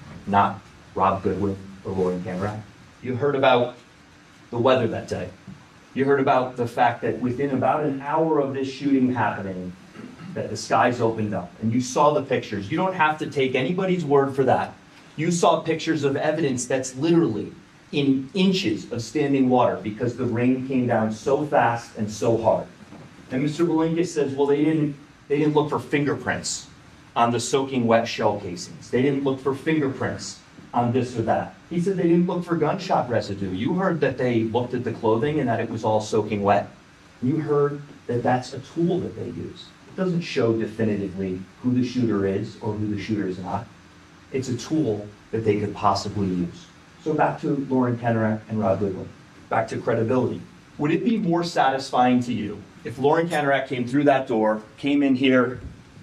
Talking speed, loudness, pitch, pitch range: 190 wpm, -23 LUFS, 125 Hz, 110-145 Hz